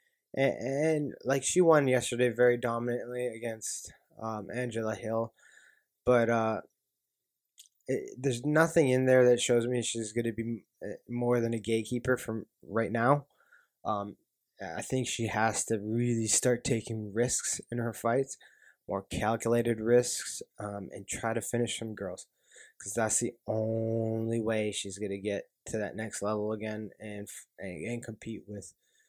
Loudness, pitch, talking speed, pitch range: -31 LUFS, 115 Hz, 155 wpm, 110-125 Hz